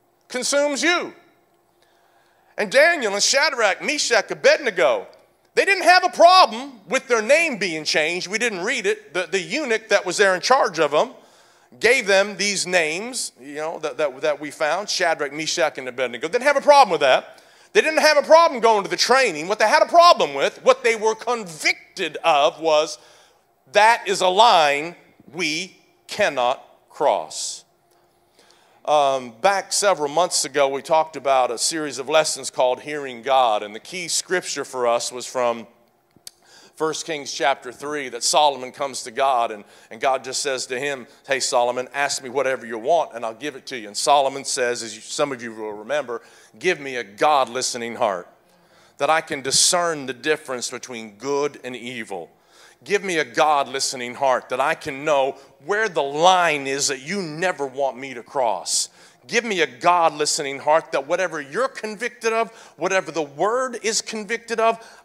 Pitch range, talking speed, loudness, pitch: 135-225 Hz, 180 wpm, -20 LUFS, 160 Hz